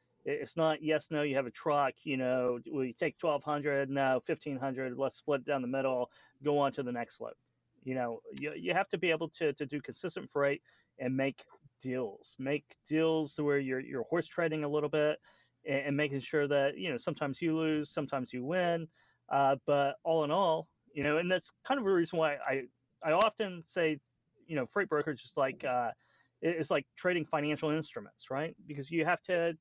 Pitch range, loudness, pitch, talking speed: 135-160 Hz, -34 LUFS, 150 Hz, 205 wpm